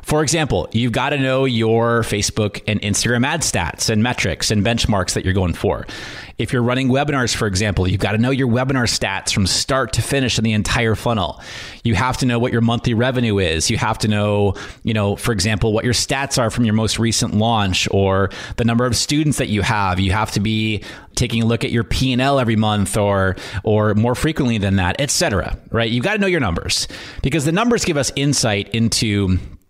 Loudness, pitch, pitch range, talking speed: -18 LUFS, 115 Hz, 105-125 Hz, 230 wpm